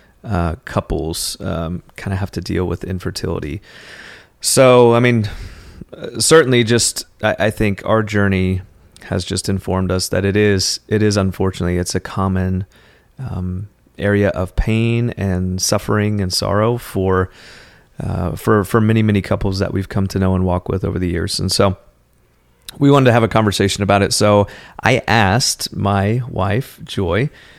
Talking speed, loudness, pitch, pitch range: 165 wpm, -17 LUFS, 100 Hz, 95-110 Hz